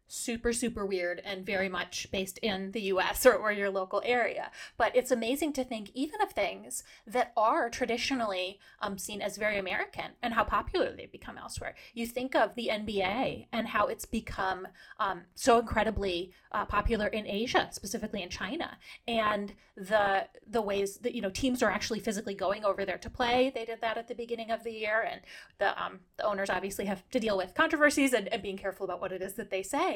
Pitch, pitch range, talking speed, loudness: 220 Hz, 200-240 Hz, 205 wpm, -31 LUFS